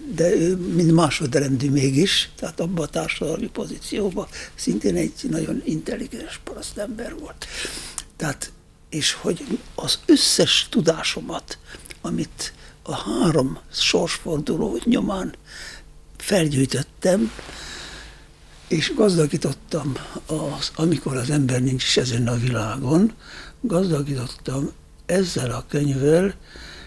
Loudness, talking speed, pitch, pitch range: -22 LUFS, 100 wpm, 155 Hz, 135-180 Hz